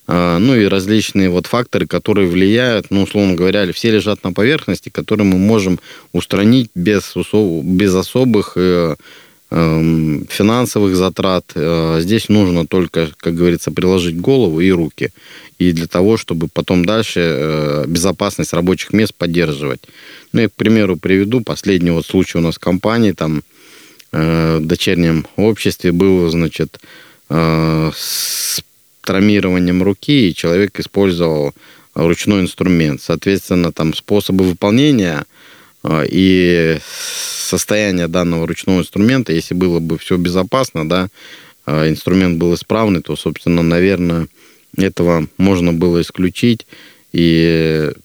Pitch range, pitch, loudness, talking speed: 85-100 Hz, 90 Hz, -14 LUFS, 125 wpm